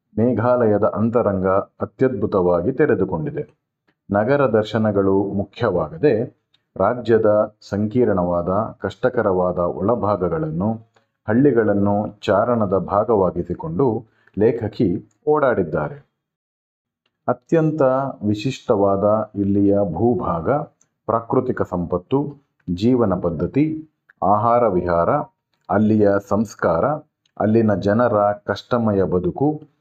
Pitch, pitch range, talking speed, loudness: 105 Hz, 100-130 Hz, 65 wpm, -19 LUFS